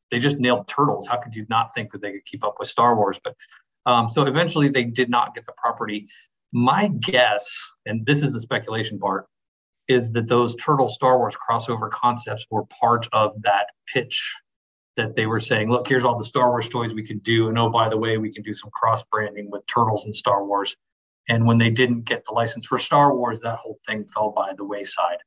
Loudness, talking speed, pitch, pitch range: -22 LUFS, 225 wpm, 115 Hz, 105-125 Hz